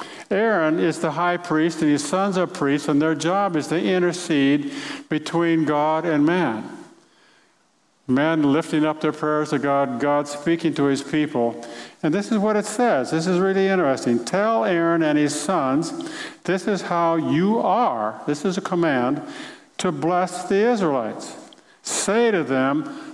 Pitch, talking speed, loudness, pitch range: 165 Hz, 165 wpm, -21 LUFS, 150-195 Hz